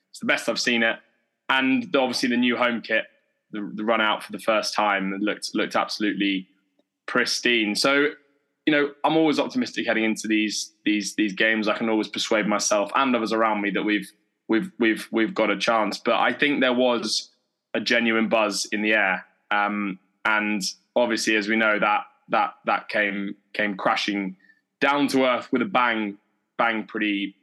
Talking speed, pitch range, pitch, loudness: 185 wpm, 105-125 Hz, 110 Hz, -23 LUFS